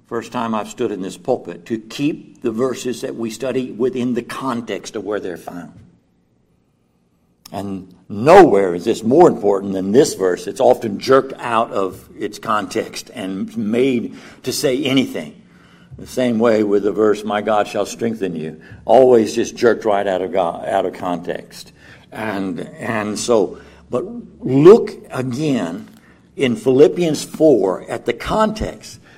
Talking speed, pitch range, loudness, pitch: 155 wpm, 95-125 Hz, -17 LUFS, 115 Hz